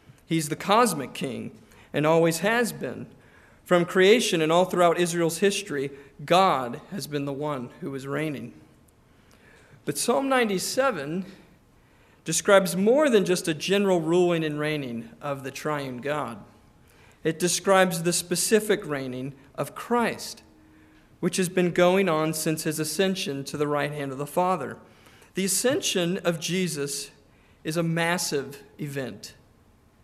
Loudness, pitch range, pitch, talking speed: -25 LUFS, 145-185 Hz, 170 Hz, 140 wpm